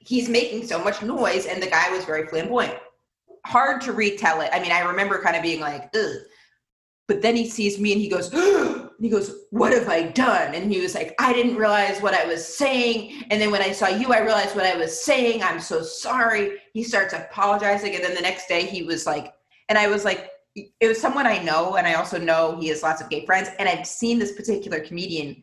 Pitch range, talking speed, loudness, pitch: 180-235 Hz, 240 wpm, -22 LUFS, 205 Hz